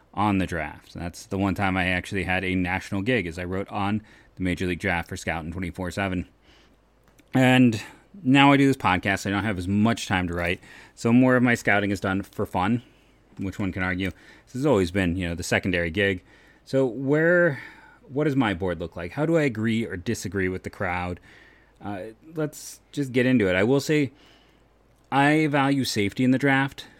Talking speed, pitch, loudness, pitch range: 210 wpm, 100 Hz, -24 LUFS, 95-130 Hz